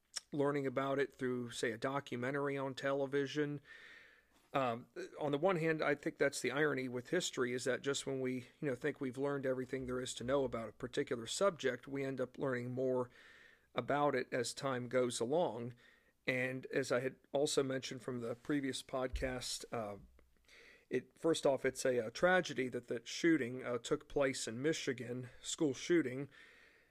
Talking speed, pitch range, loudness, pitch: 175 wpm, 125-145 Hz, -38 LUFS, 135 Hz